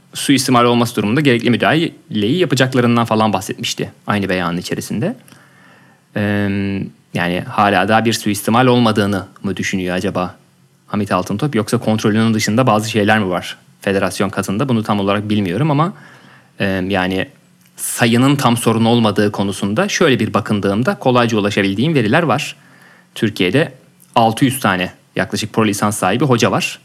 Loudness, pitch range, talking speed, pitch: -16 LUFS, 100-120 Hz, 130 wpm, 110 Hz